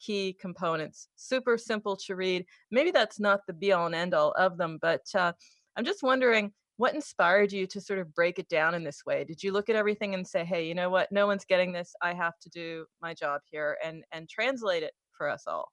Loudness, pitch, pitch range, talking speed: -29 LUFS, 190 Hz, 170-210 Hz, 240 wpm